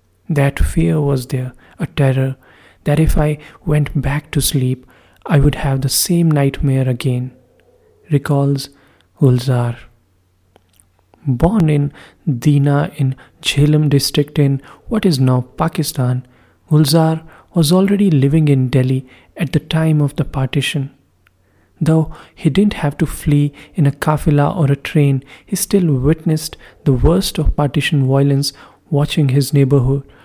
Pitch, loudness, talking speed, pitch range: 145 Hz, -16 LUFS, 135 wpm, 130-155 Hz